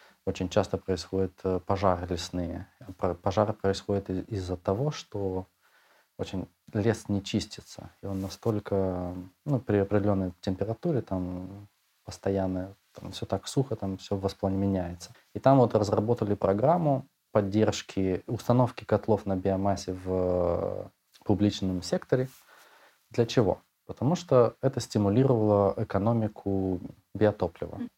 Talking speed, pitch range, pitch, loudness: 110 wpm, 95-110 Hz, 100 Hz, -29 LUFS